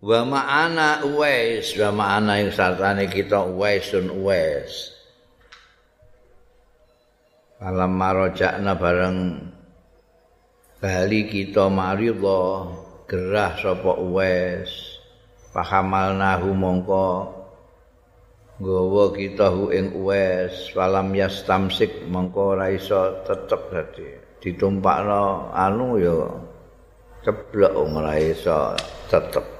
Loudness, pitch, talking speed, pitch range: -21 LUFS, 95 Hz, 80 wpm, 95-115 Hz